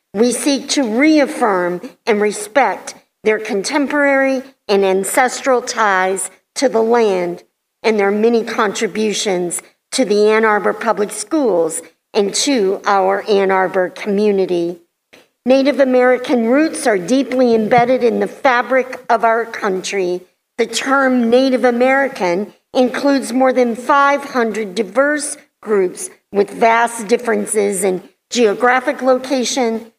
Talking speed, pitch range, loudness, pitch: 115 wpm, 205-260 Hz, -15 LUFS, 230 Hz